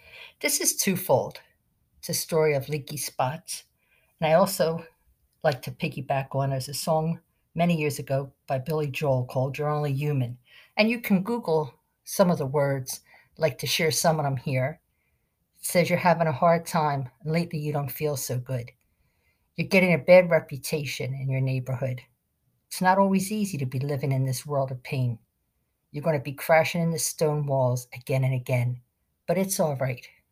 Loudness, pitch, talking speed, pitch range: -26 LUFS, 145 Hz, 190 wpm, 130-165 Hz